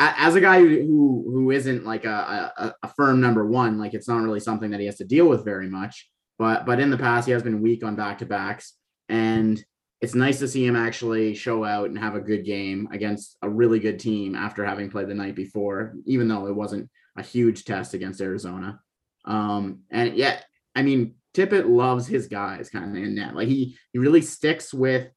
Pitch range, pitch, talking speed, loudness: 105-125 Hz, 110 Hz, 215 wpm, -23 LUFS